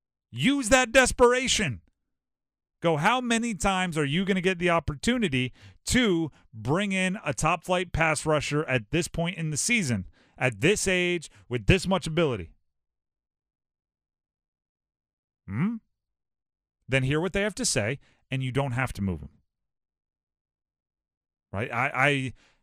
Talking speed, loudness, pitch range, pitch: 140 wpm, -26 LUFS, 120-190 Hz, 150 Hz